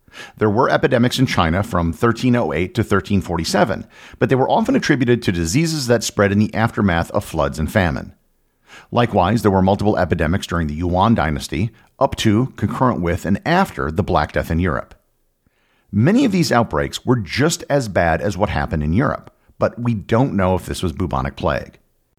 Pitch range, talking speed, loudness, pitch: 85-120 Hz, 180 wpm, -18 LUFS, 100 Hz